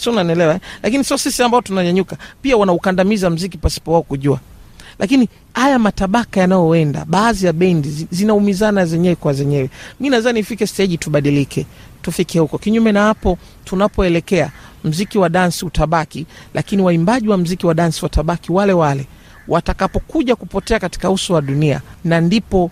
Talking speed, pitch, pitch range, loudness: 150 wpm, 180 Hz, 165-205 Hz, -16 LUFS